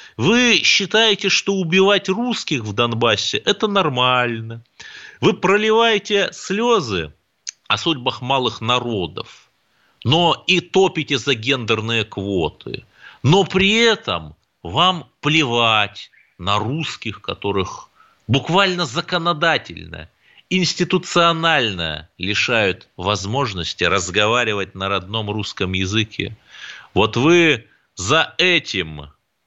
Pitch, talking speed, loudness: 140 Hz, 90 wpm, -18 LUFS